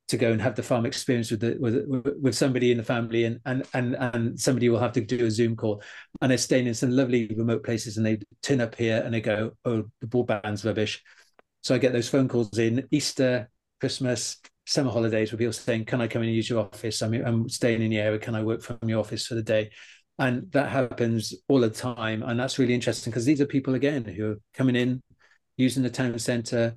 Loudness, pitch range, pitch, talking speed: -26 LUFS, 115-130 Hz, 120 Hz, 240 wpm